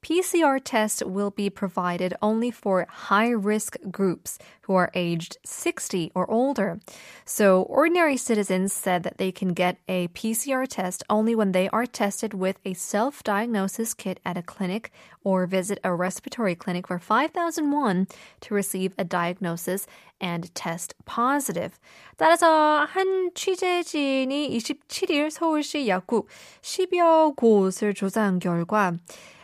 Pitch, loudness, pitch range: 210 Hz, -25 LUFS, 185-270 Hz